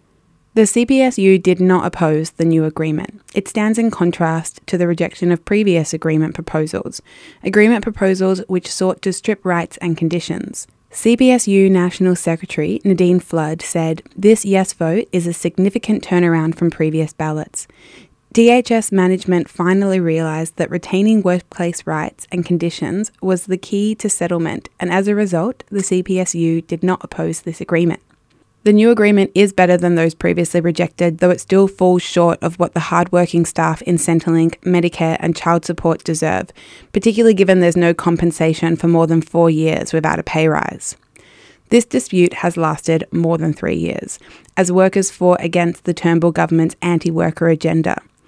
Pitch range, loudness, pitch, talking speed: 165-190 Hz, -16 LUFS, 175 Hz, 160 wpm